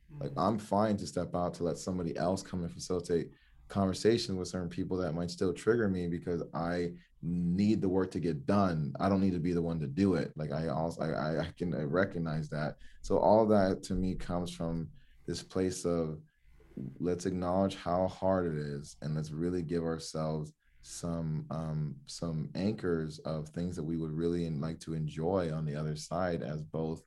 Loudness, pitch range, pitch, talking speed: -33 LUFS, 80-90 Hz, 85 Hz, 195 wpm